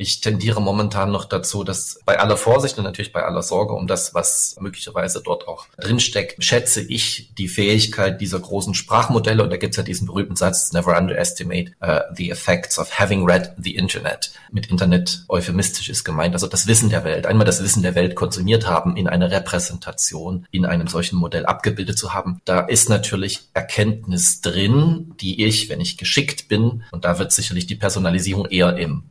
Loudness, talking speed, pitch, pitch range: -19 LUFS, 190 wpm, 95 Hz, 90-110 Hz